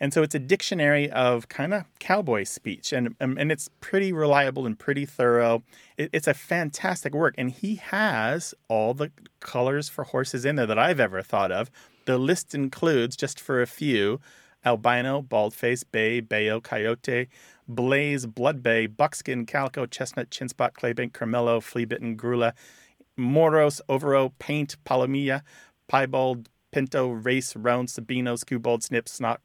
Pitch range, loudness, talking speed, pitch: 120-145 Hz, -25 LUFS, 155 wpm, 130 Hz